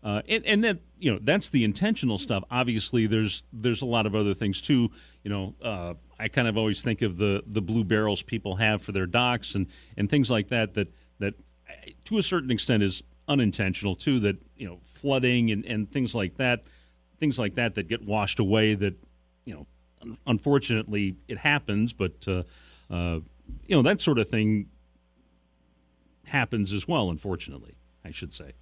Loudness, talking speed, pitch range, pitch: -27 LUFS, 190 wpm, 90-120 Hz, 105 Hz